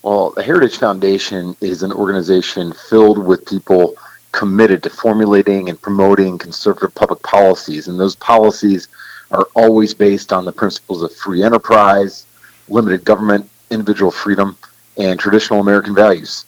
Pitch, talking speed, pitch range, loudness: 100 Hz, 140 wpm, 95-105 Hz, -13 LUFS